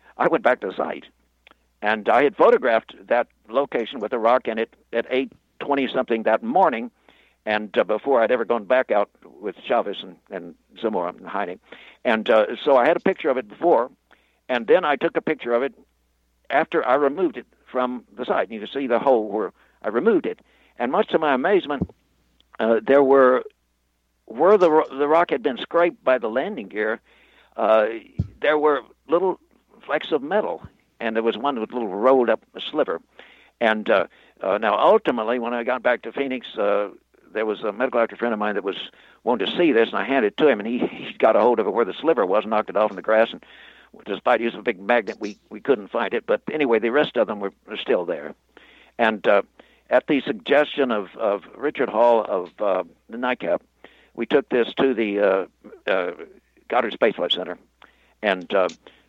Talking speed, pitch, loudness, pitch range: 210 wpm, 120 Hz, -22 LUFS, 110-140 Hz